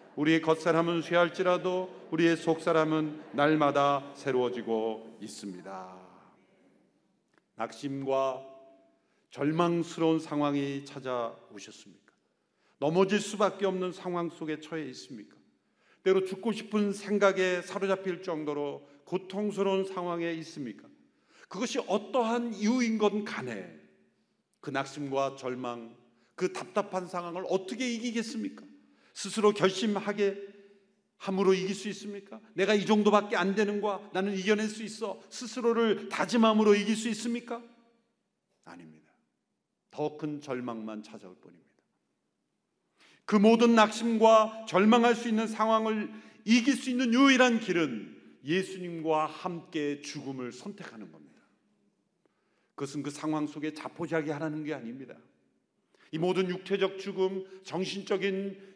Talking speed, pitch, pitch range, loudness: 275 characters per minute, 185 Hz, 150-210 Hz, -29 LUFS